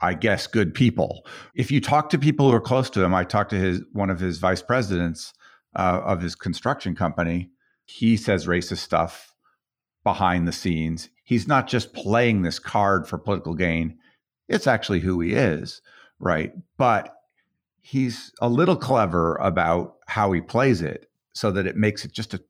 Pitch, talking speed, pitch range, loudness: 100 Hz, 180 wpm, 90-120 Hz, -23 LUFS